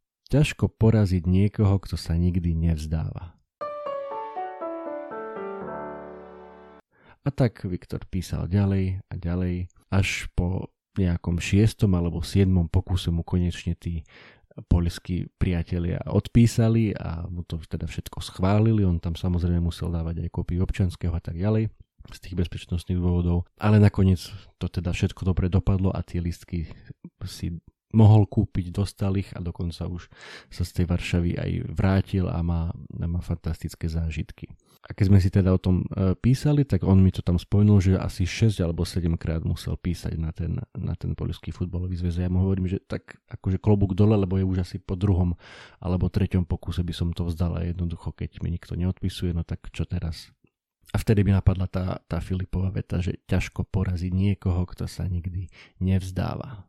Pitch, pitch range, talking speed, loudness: 90 Hz, 85-100 Hz, 160 wpm, -26 LUFS